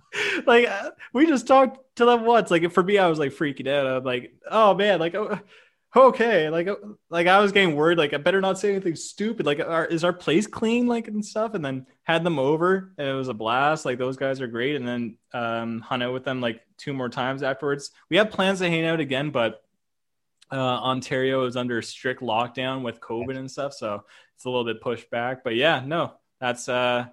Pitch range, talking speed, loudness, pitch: 130-200 Hz, 225 wpm, -23 LUFS, 150 Hz